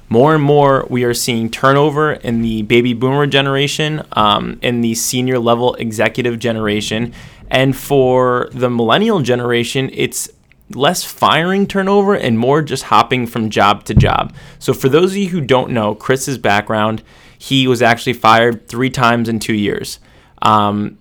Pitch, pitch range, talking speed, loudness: 125 Hz, 115-135 Hz, 160 wpm, -14 LUFS